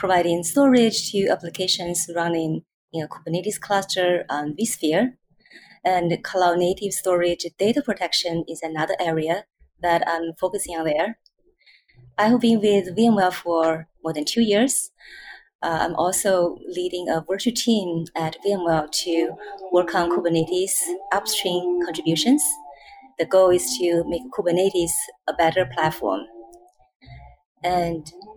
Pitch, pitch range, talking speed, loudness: 175 Hz, 165-200 Hz, 125 wpm, -22 LUFS